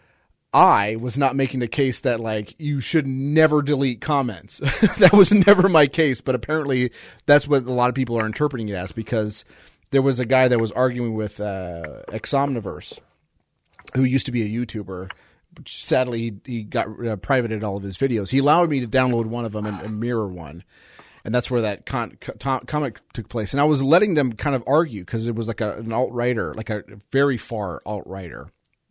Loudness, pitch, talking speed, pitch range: -21 LUFS, 125 Hz, 205 wpm, 110-135 Hz